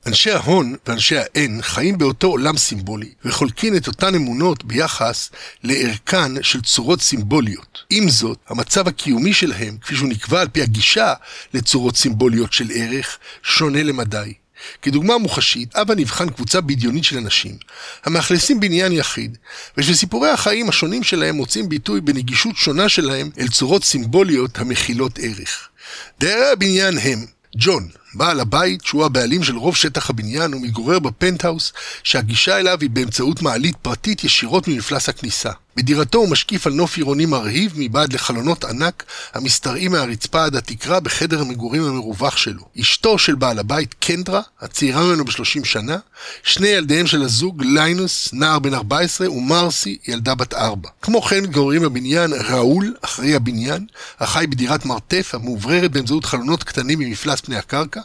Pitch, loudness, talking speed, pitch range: 145 Hz, -17 LUFS, 140 wpm, 125-175 Hz